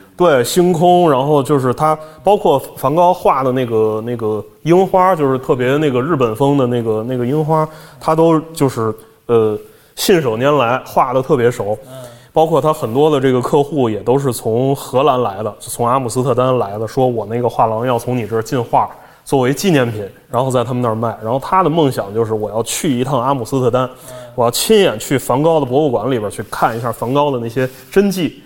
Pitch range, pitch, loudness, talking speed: 115-150 Hz, 130 Hz, -15 LUFS, 305 characters per minute